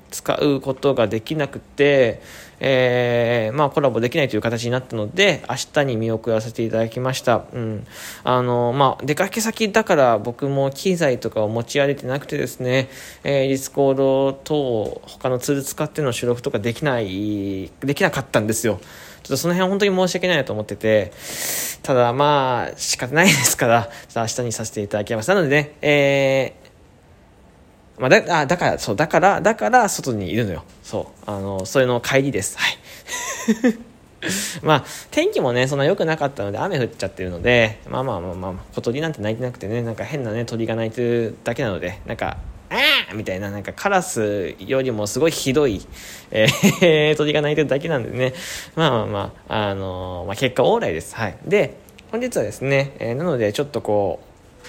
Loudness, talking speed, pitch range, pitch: -20 LUFS, 370 characters per minute, 110-145 Hz, 125 Hz